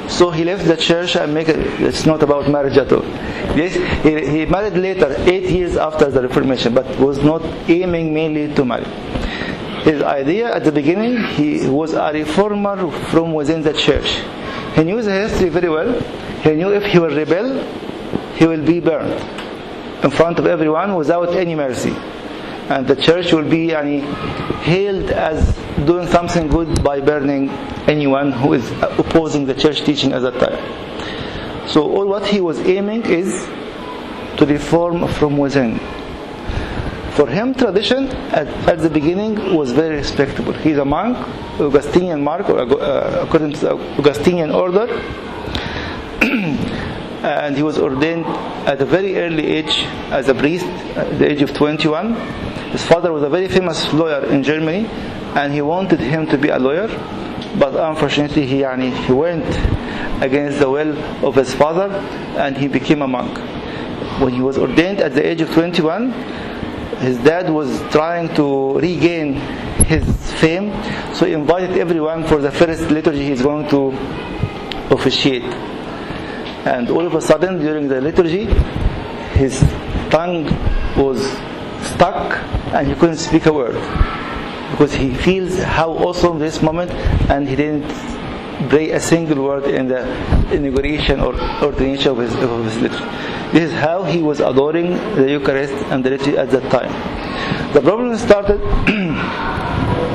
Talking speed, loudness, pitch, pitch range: 155 wpm, -17 LUFS, 155 Hz, 145-175 Hz